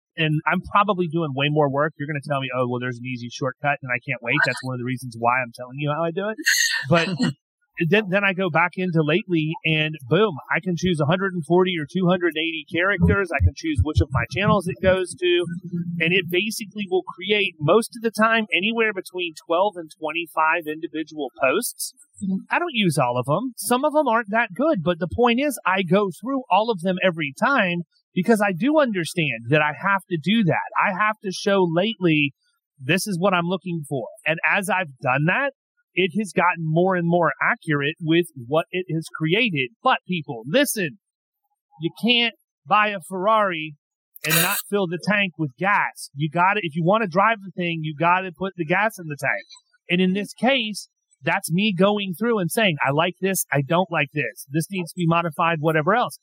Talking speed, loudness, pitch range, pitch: 210 wpm, -22 LUFS, 160-205 Hz, 180 Hz